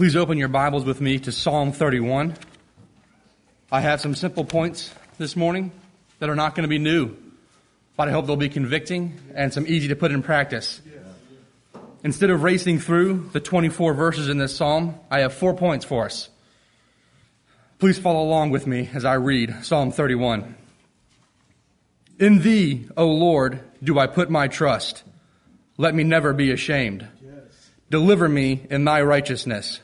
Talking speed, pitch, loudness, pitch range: 165 wpm, 150 Hz, -21 LUFS, 135-165 Hz